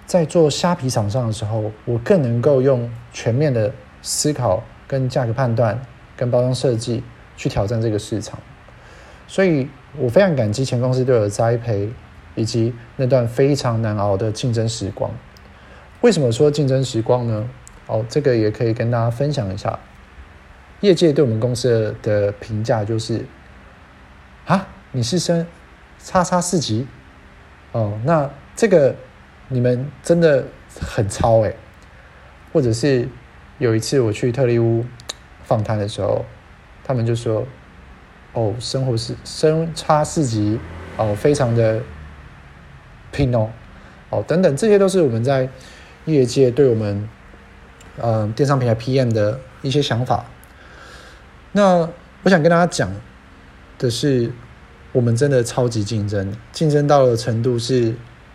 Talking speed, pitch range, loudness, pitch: 210 characters per minute, 105-135 Hz, -19 LUFS, 115 Hz